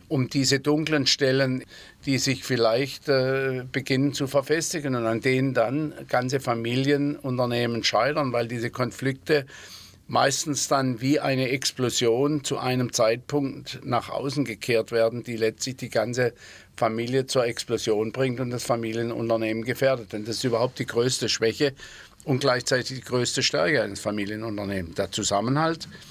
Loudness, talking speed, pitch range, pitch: -25 LUFS, 140 wpm, 115-140 Hz, 130 Hz